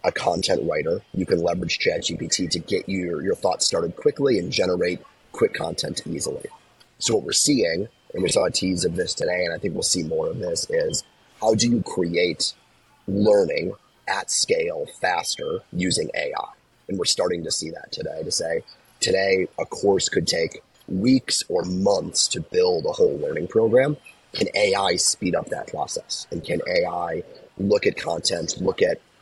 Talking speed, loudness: 180 wpm, -23 LUFS